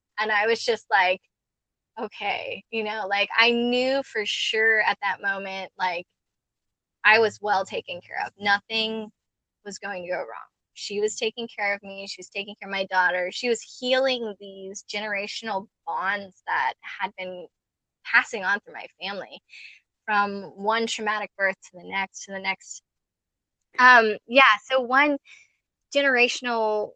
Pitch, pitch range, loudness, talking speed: 205 Hz, 195-230 Hz, -24 LUFS, 160 wpm